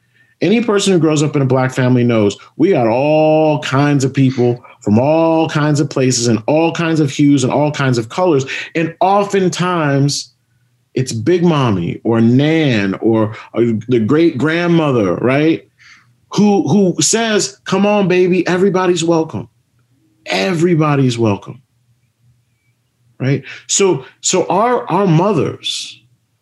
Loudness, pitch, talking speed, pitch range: -14 LUFS, 140 Hz, 135 wpm, 120-165 Hz